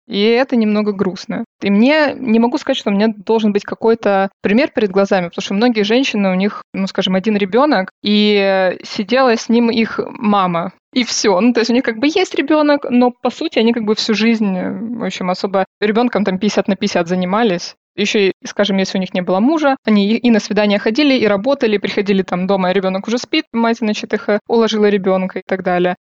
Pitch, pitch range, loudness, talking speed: 215 Hz, 195-235 Hz, -15 LUFS, 215 wpm